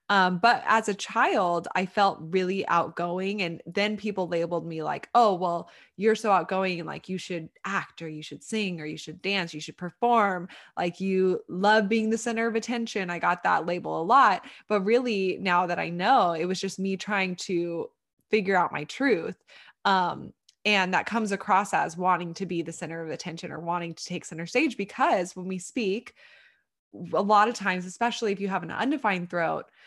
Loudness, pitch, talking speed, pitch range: -26 LUFS, 185 Hz, 200 wpm, 175-210 Hz